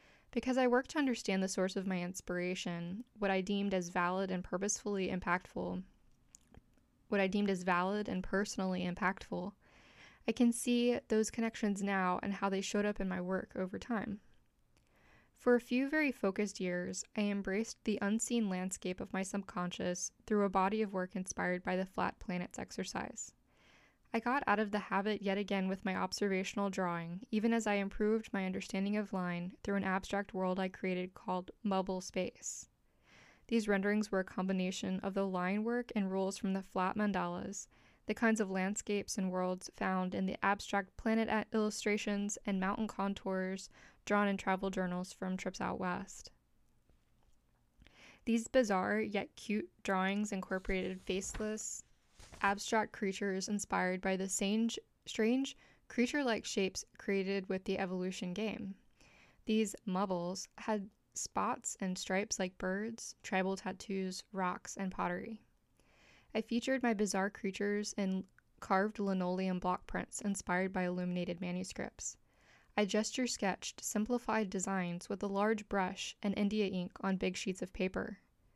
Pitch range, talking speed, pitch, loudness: 185-210 Hz, 155 wpm, 195 Hz, -37 LUFS